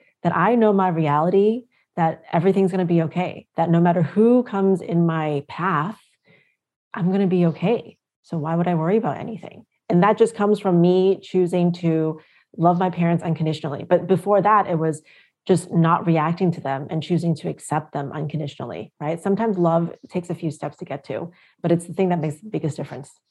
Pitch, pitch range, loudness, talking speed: 175 Hz, 160-190 Hz, -21 LUFS, 195 wpm